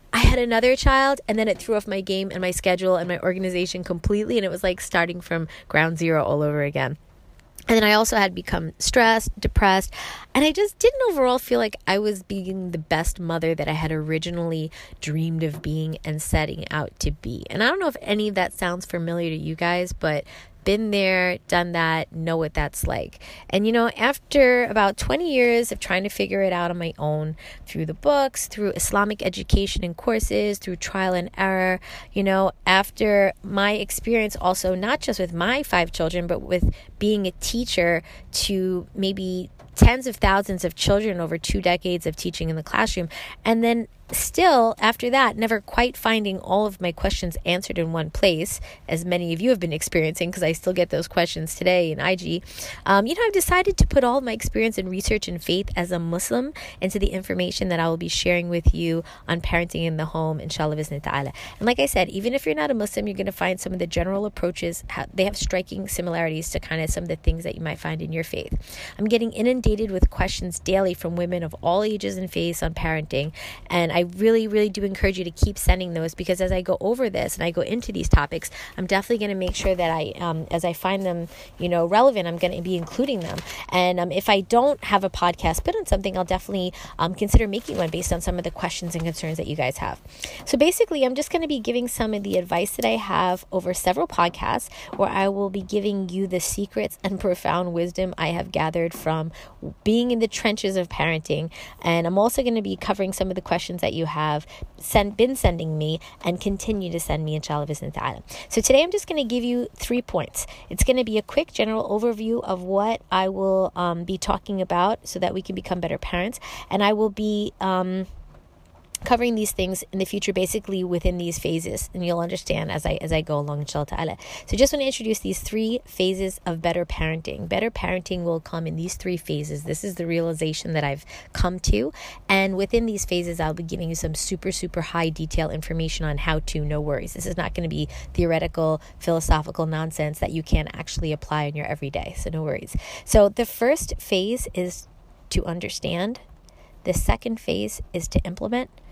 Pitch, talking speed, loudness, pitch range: 180 Hz, 220 wpm, -23 LUFS, 165-210 Hz